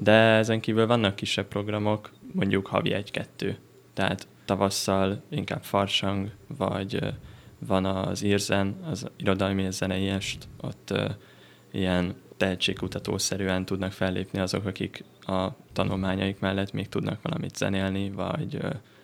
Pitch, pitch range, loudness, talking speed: 95 Hz, 95-105 Hz, -28 LUFS, 125 wpm